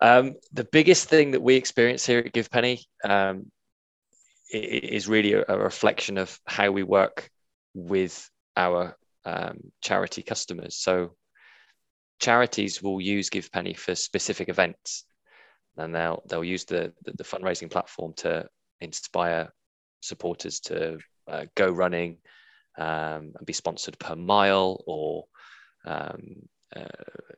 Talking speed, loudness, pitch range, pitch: 125 wpm, -26 LUFS, 90-120 Hz, 100 Hz